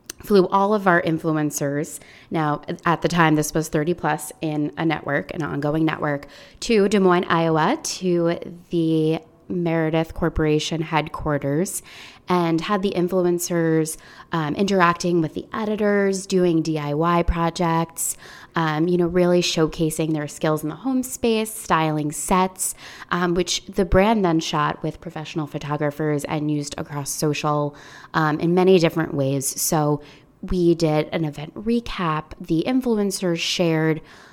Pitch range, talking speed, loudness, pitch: 150-180 Hz, 140 wpm, -22 LUFS, 165 Hz